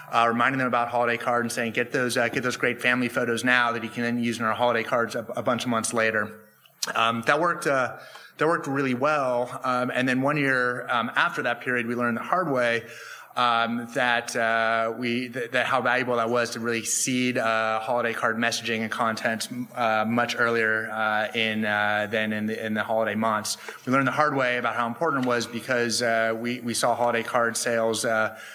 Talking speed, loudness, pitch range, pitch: 220 wpm, -24 LUFS, 115-125 Hz, 120 Hz